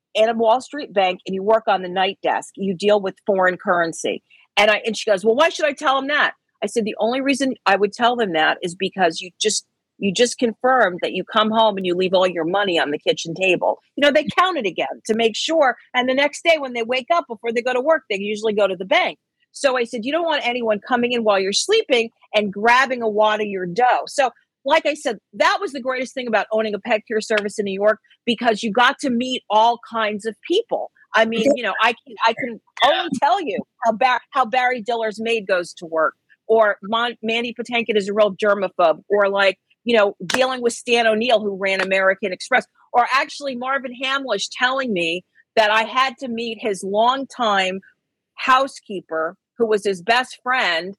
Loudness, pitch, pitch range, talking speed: -19 LUFS, 225 Hz, 200-255 Hz, 225 wpm